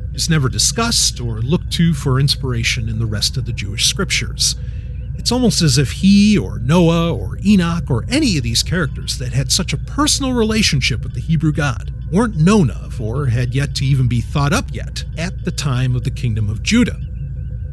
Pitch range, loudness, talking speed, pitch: 120-165 Hz, -16 LUFS, 200 wpm, 135 Hz